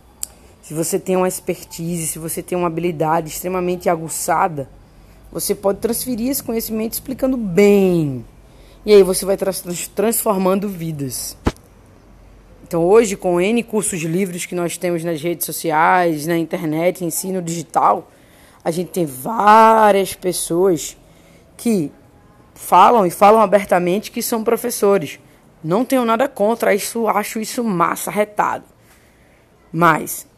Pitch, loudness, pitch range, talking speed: 185 Hz, -17 LUFS, 165-210 Hz, 130 wpm